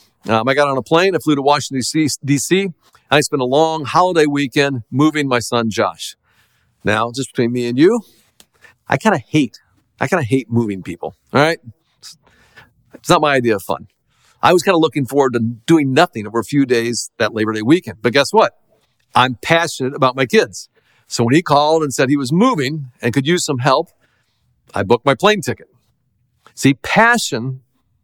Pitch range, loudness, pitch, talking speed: 120-150 Hz, -16 LUFS, 135 Hz, 195 wpm